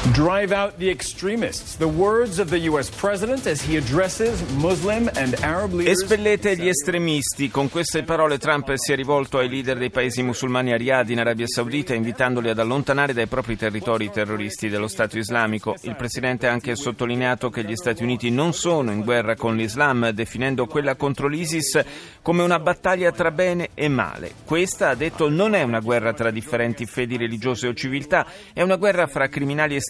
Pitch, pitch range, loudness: 135 Hz, 120-170 Hz, -22 LUFS